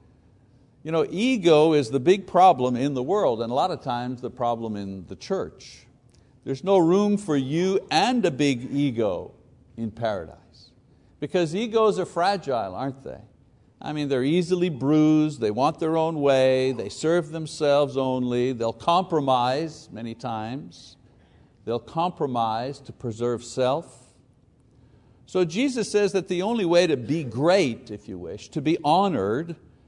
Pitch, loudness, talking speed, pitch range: 140 Hz, -24 LUFS, 155 wpm, 120-170 Hz